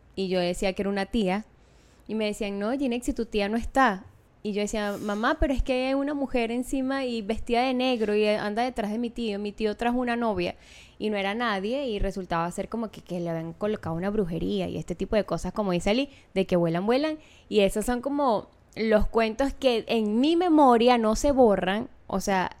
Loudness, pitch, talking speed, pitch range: -26 LUFS, 215 Hz, 225 wpm, 200-245 Hz